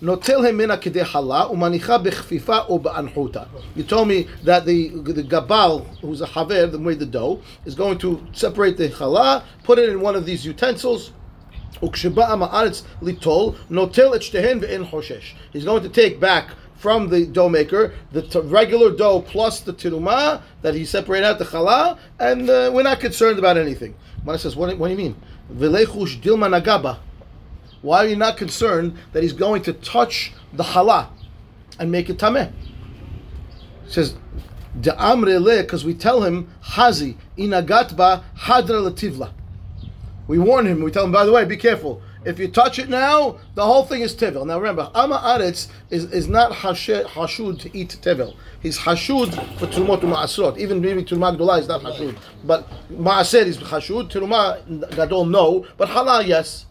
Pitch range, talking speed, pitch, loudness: 160-220 Hz, 150 wpm, 180 Hz, -18 LUFS